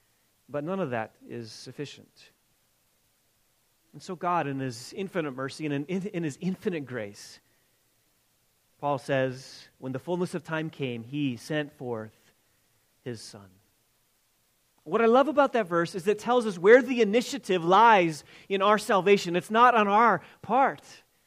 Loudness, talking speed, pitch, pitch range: -26 LUFS, 155 wpm, 155 Hz, 125-195 Hz